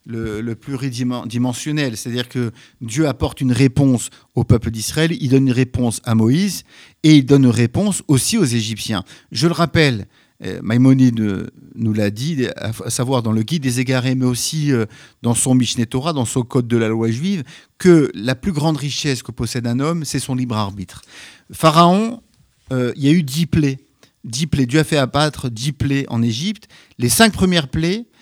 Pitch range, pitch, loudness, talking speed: 120-155 Hz, 130 Hz, -17 LUFS, 185 wpm